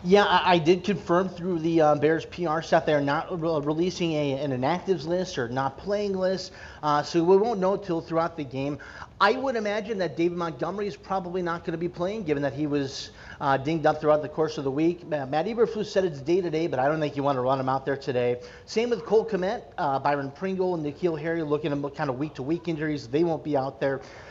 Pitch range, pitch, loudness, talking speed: 145-185 Hz, 165 Hz, -26 LUFS, 250 wpm